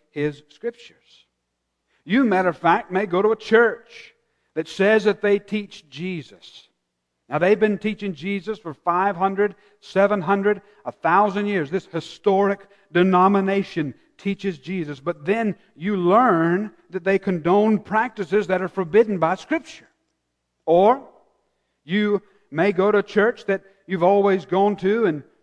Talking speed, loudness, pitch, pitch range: 135 wpm, -21 LUFS, 195 Hz, 175-205 Hz